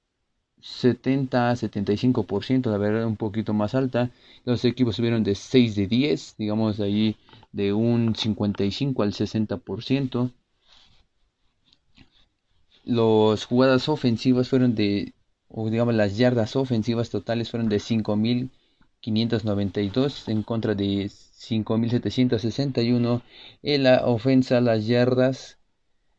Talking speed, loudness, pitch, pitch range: 110 wpm, -23 LUFS, 115 Hz, 105-125 Hz